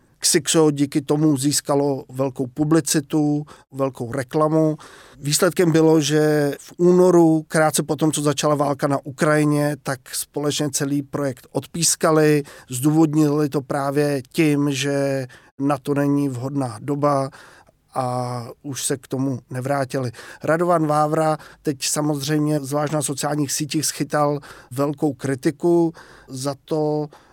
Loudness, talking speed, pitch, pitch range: -20 LUFS, 120 wpm, 145 Hz, 140-155 Hz